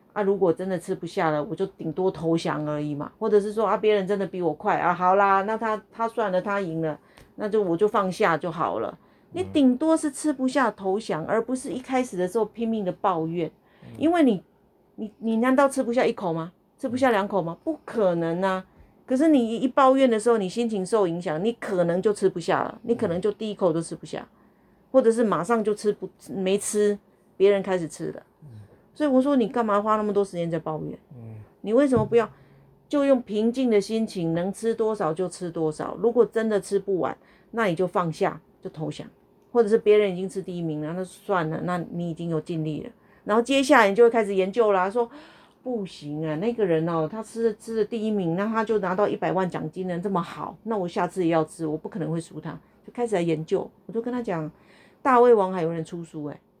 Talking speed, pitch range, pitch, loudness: 315 characters per minute, 175-225 Hz, 200 Hz, -24 LUFS